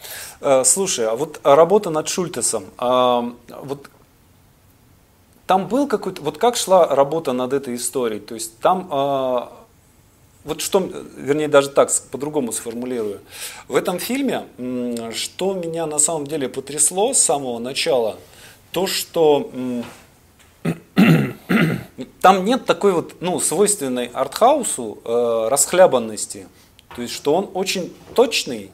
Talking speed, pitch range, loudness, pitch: 115 wpm, 120-185 Hz, -19 LUFS, 140 Hz